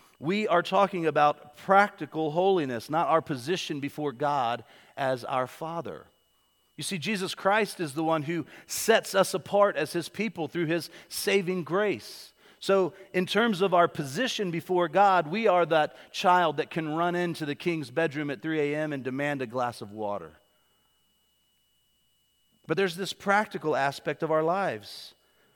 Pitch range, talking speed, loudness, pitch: 145-190 Hz, 160 wpm, -27 LUFS, 165 Hz